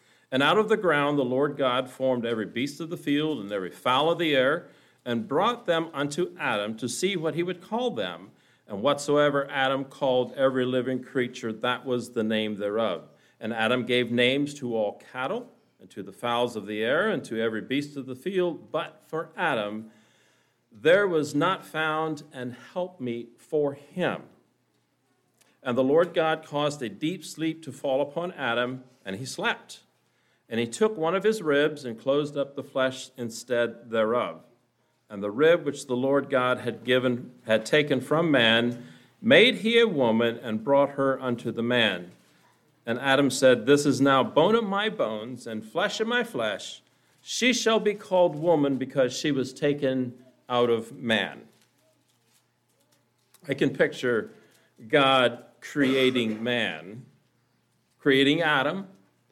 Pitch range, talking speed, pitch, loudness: 120-155 Hz, 165 wpm, 130 Hz, -26 LUFS